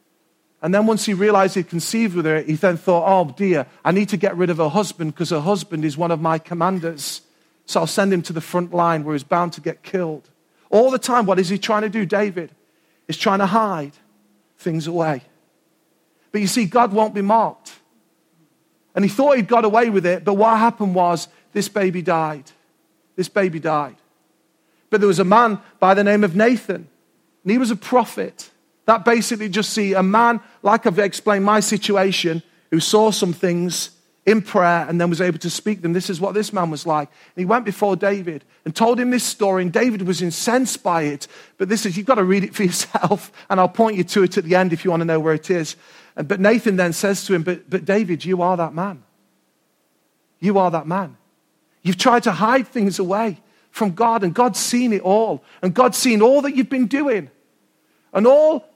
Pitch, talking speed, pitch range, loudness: 190 Hz, 220 wpm, 170-215 Hz, -18 LUFS